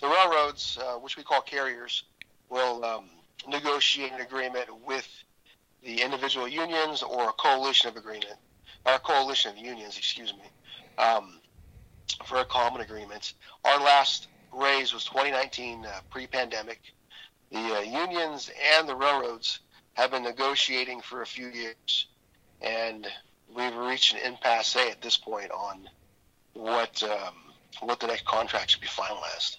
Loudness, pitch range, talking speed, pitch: -27 LUFS, 115-135 Hz, 145 wpm, 125 Hz